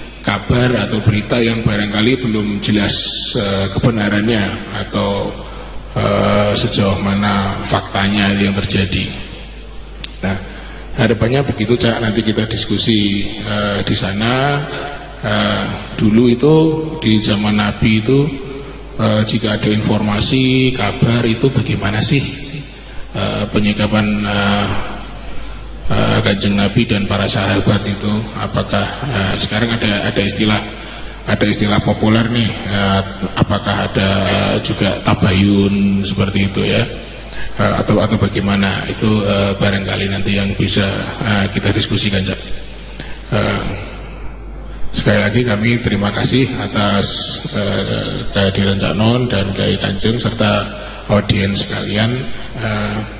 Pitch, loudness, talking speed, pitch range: 105 Hz, -14 LUFS, 110 wpm, 100-115 Hz